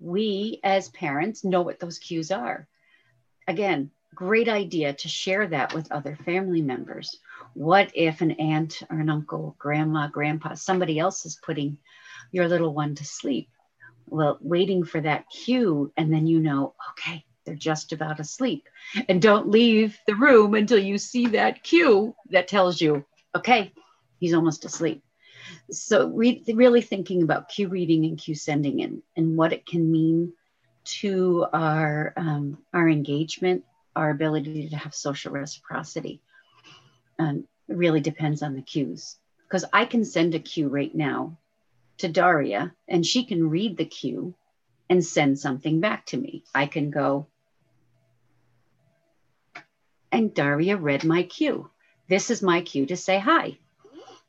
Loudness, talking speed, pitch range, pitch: -24 LUFS, 155 wpm, 150-190 Hz, 160 Hz